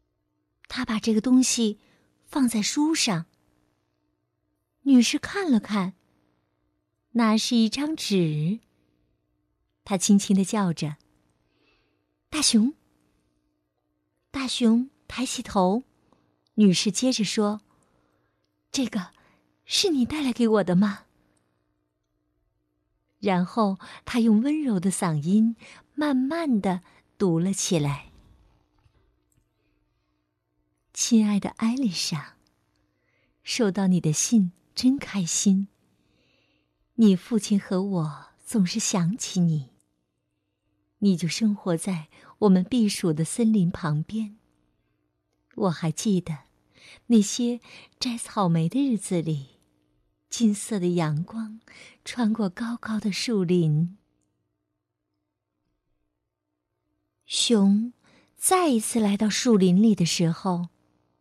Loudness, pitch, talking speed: -24 LUFS, 185 Hz, 135 characters per minute